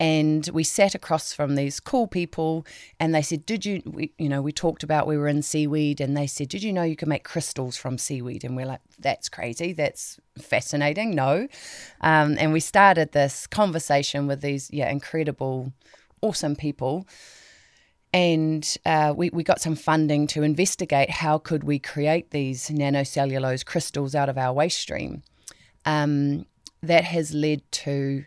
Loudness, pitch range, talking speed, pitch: -24 LUFS, 140-160 Hz, 170 wpm, 150 Hz